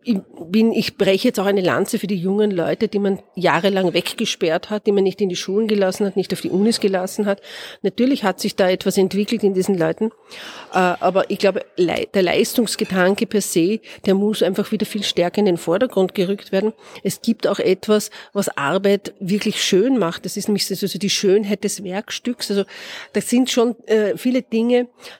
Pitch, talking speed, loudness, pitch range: 200 Hz, 195 wpm, -19 LUFS, 190-220 Hz